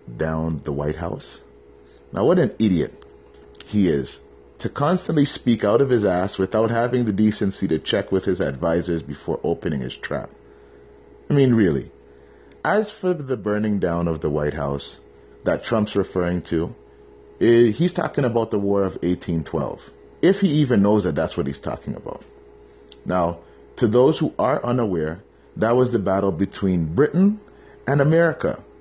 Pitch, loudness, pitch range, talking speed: 95 Hz, -21 LUFS, 70-115 Hz, 160 wpm